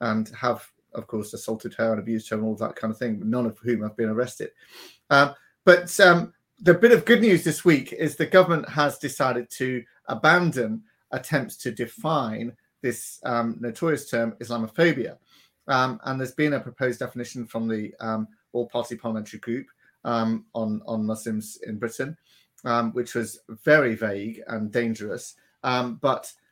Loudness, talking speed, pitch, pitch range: -24 LUFS, 170 wpm, 120 Hz, 110-140 Hz